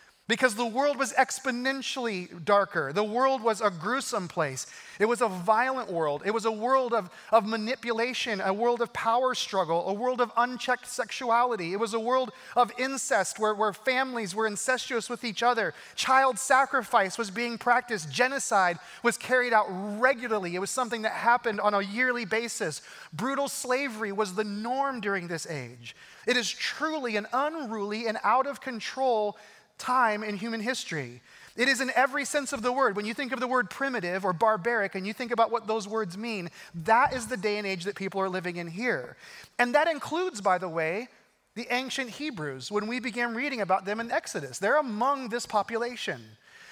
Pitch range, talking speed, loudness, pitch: 205-255 Hz, 190 wpm, -28 LUFS, 235 Hz